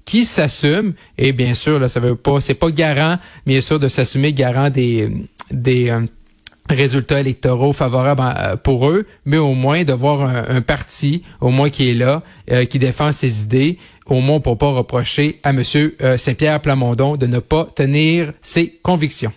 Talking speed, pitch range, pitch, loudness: 190 wpm, 125-150 Hz, 140 Hz, -16 LUFS